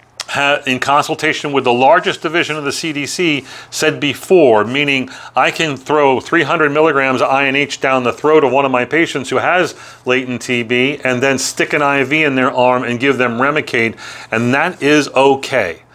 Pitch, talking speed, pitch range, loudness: 135 Hz, 175 wpm, 125-150 Hz, -14 LUFS